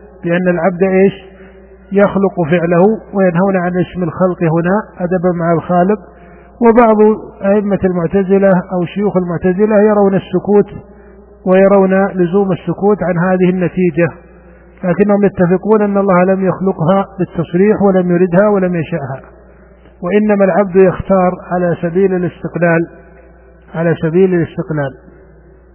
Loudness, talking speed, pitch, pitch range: -12 LUFS, 110 wpm, 185 Hz, 175-195 Hz